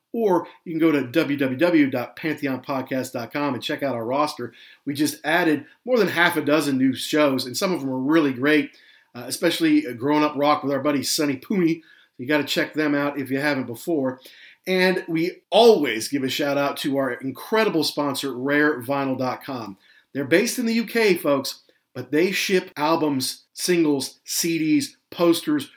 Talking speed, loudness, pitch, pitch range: 170 wpm, -22 LUFS, 150 Hz, 135-165 Hz